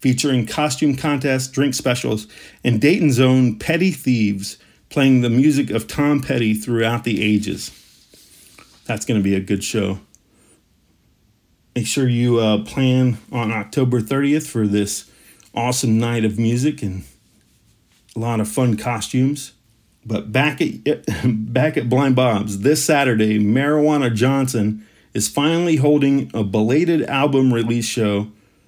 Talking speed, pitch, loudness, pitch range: 135 wpm, 120 Hz, -18 LUFS, 105-135 Hz